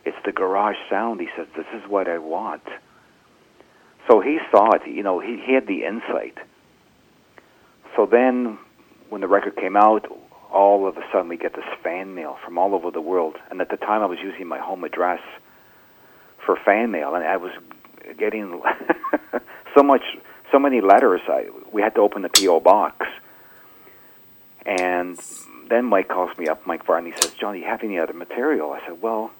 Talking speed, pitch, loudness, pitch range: 185 wpm, 105 Hz, -21 LUFS, 95-120 Hz